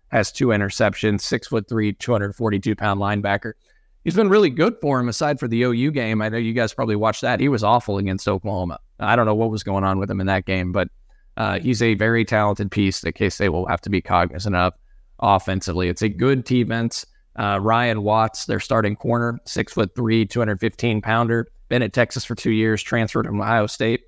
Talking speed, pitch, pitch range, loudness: 225 wpm, 110 Hz, 100-120 Hz, -21 LUFS